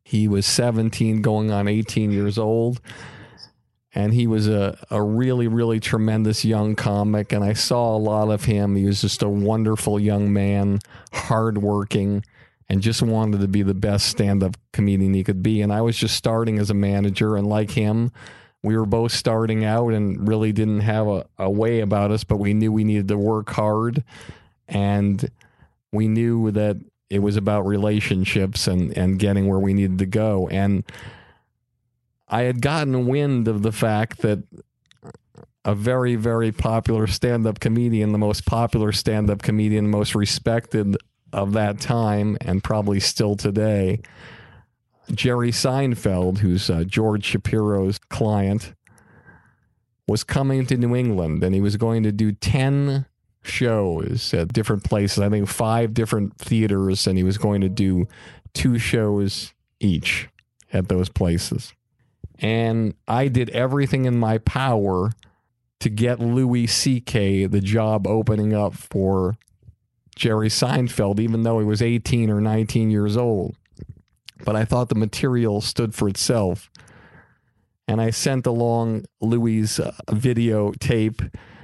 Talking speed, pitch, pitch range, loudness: 155 wpm, 110 Hz, 100-115 Hz, -21 LUFS